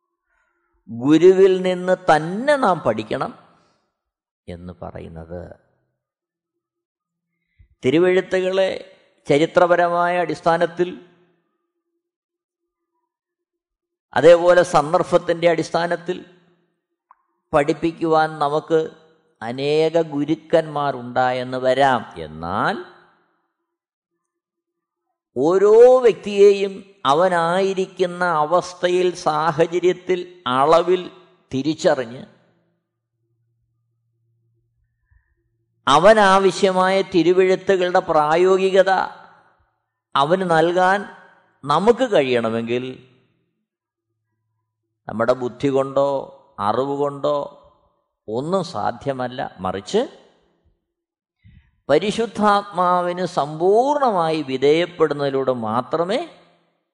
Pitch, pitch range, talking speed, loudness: 170 Hz, 140-190 Hz, 45 wpm, -18 LUFS